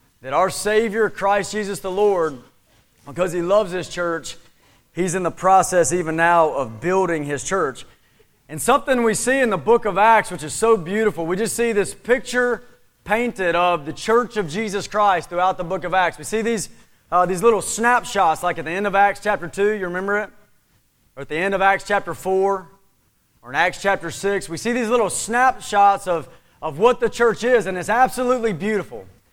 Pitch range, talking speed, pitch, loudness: 170-220 Hz, 200 wpm, 195 Hz, -20 LUFS